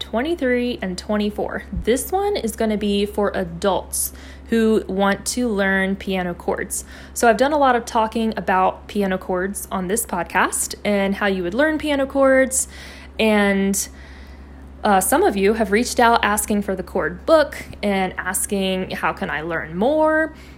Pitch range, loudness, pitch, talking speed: 185-235 Hz, -20 LUFS, 205 Hz, 165 wpm